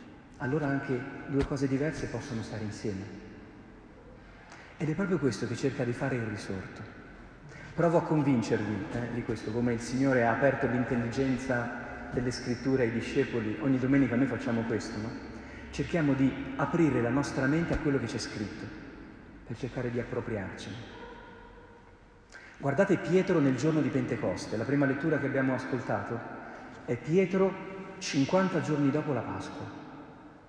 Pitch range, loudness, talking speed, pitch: 115-145 Hz, -30 LUFS, 145 wpm, 130 Hz